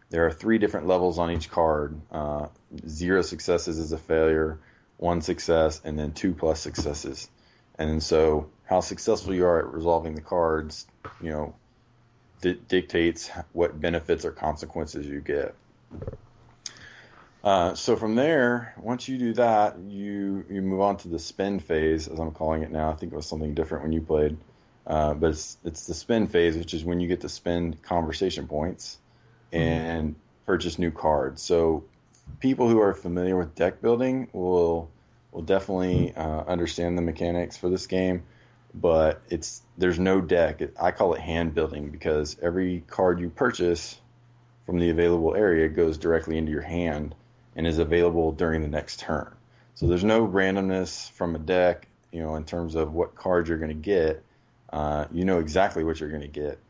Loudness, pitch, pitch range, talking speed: -26 LUFS, 85 Hz, 80-95 Hz, 175 wpm